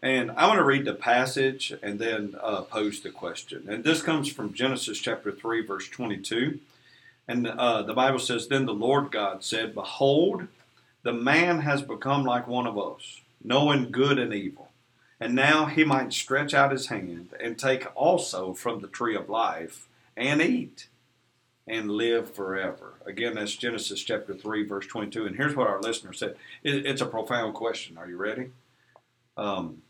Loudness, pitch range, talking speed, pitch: -27 LUFS, 110-135 Hz, 175 wpm, 120 Hz